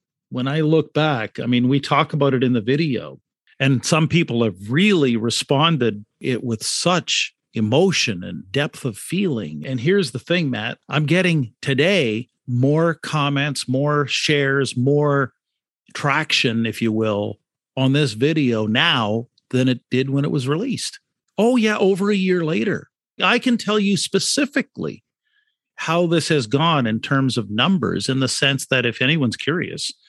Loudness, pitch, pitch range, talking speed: -19 LUFS, 140 Hz, 125-170 Hz, 160 wpm